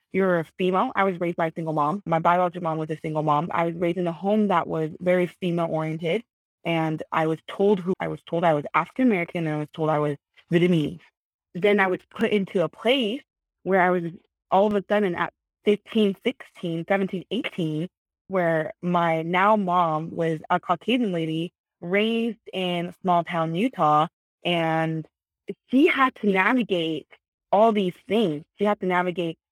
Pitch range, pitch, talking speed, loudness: 165-200 Hz, 180 Hz, 185 wpm, -24 LUFS